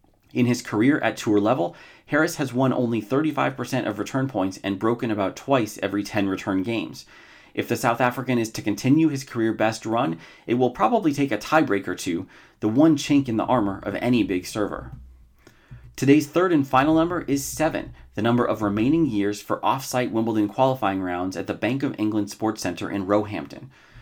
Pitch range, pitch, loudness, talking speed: 105-135 Hz, 115 Hz, -23 LUFS, 190 wpm